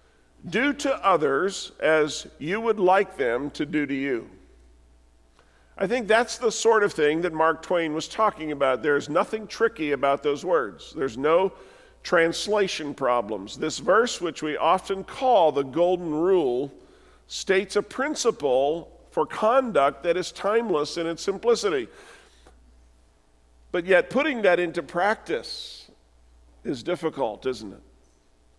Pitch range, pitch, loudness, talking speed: 135-210 Hz, 165 Hz, -24 LUFS, 135 wpm